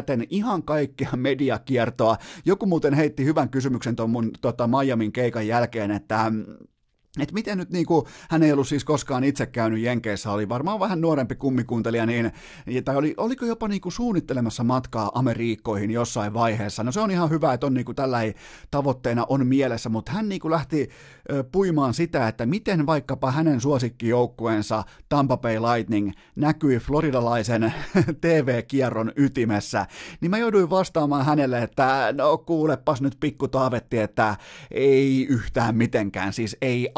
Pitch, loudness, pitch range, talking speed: 130 Hz, -23 LUFS, 115-150 Hz, 150 wpm